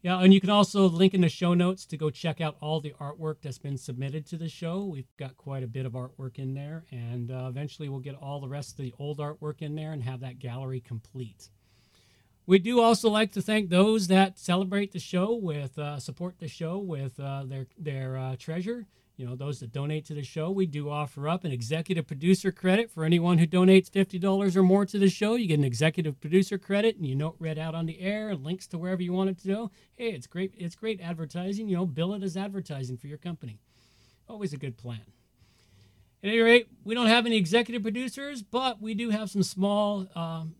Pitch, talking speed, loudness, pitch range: 165 Hz, 230 wpm, -28 LUFS, 140-195 Hz